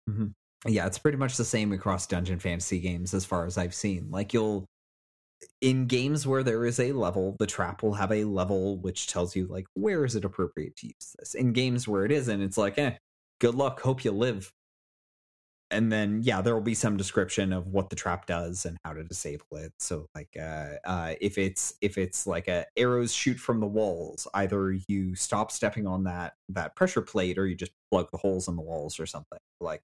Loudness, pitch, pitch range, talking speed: -29 LUFS, 95 Hz, 90-110 Hz, 220 wpm